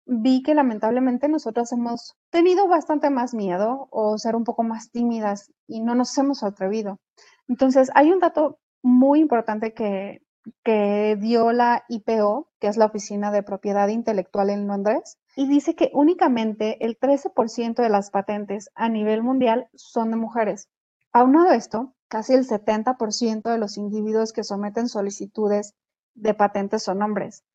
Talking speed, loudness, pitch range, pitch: 150 wpm, -22 LUFS, 210-255 Hz, 230 Hz